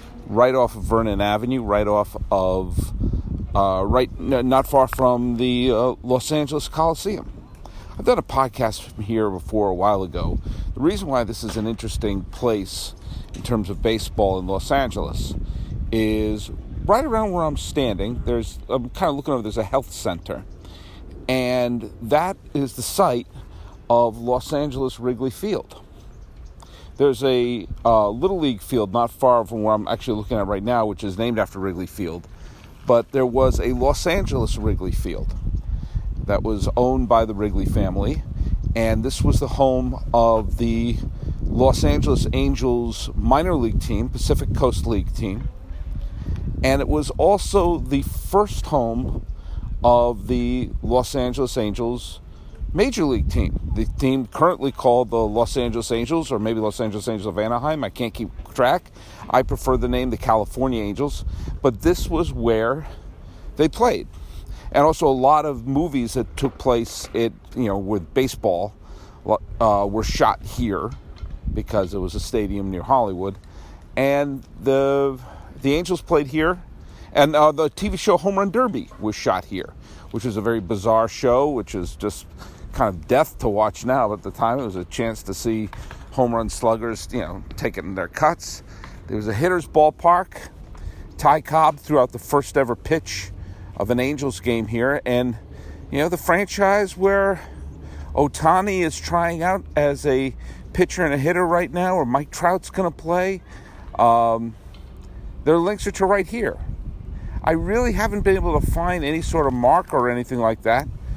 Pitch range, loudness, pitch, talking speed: 100-135 Hz, -21 LUFS, 115 Hz, 165 wpm